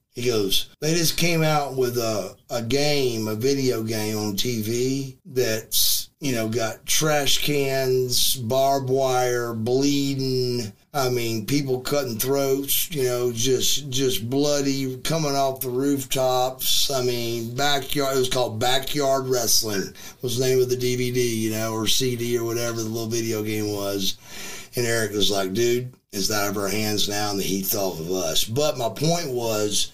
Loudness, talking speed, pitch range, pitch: -23 LUFS, 170 wpm, 110-135 Hz, 125 Hz